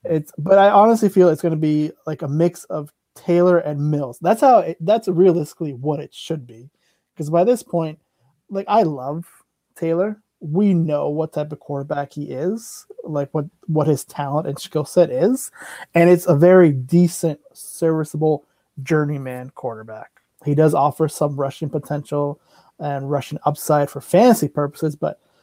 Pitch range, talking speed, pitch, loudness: 145-175 Hz, 170 wpm, 155 Hz, -19 LUFS